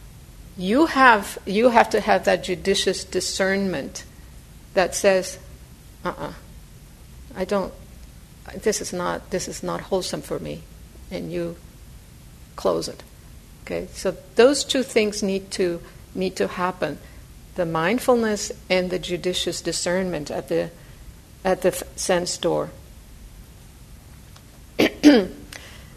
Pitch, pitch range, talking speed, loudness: 185 Hz, 175-195 Hz, 120 wpm, -22 LUFS